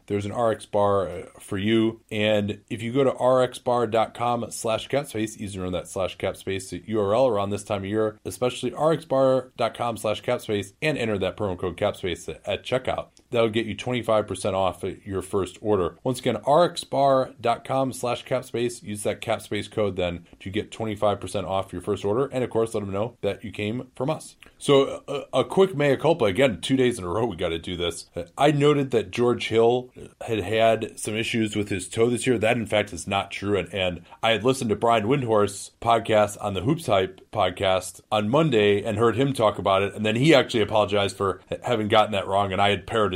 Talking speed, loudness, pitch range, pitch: 205 wpm, -24 LUFS, 100-125 Hz, 110 Hz